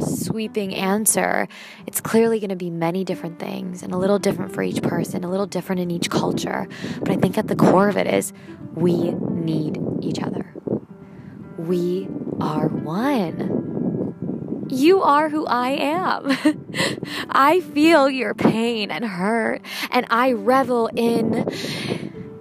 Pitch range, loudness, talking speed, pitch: 185-240 Hz, -21 LUFS, 145 wpm, 205 Hz